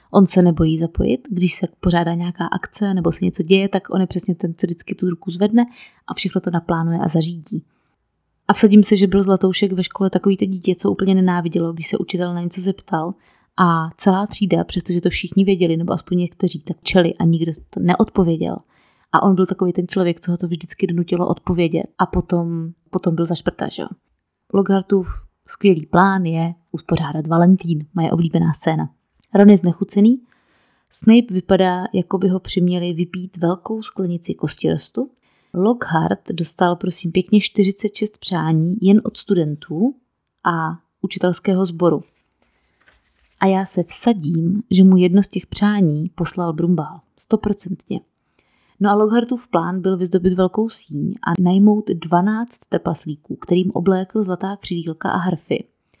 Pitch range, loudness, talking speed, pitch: 170-195 Hz, -18 LUFS, 160 wpm, 185 Hz